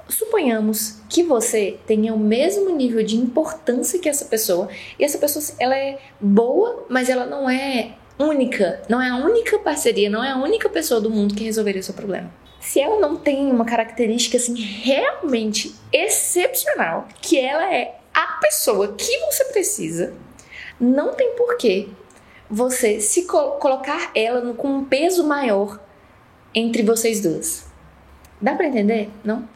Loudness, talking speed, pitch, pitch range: -20 LUFS, 155 wpm, 255 Hz, 220-310 Hz